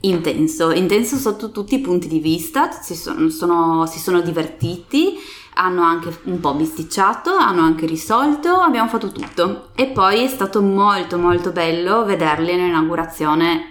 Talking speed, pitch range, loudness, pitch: 140 wpm, 165-225 Hz, -17 LUFS, 180 Hz